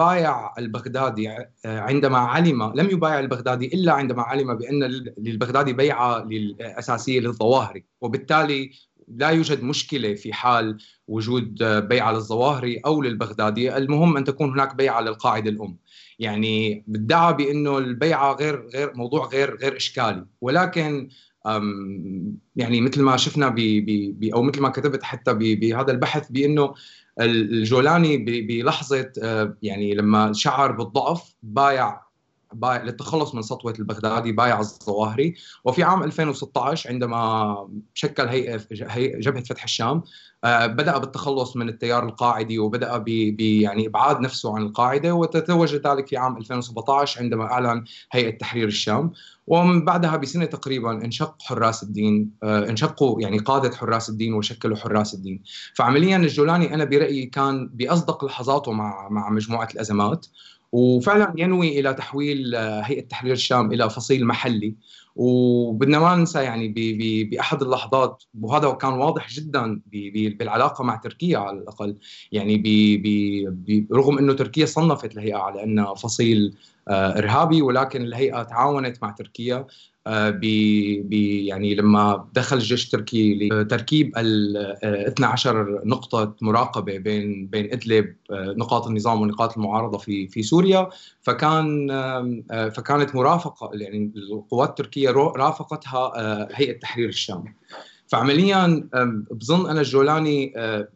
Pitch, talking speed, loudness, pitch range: 120 Hz, 120 wpm, -22 LUFS, 110-140 Hz